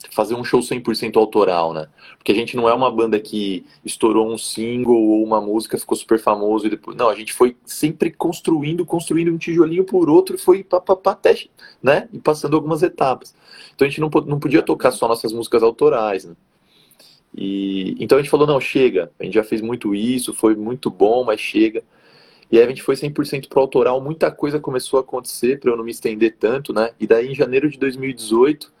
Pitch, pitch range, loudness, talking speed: 135 Hz, 110-165 Hz, -18 LUFS, 210 wpm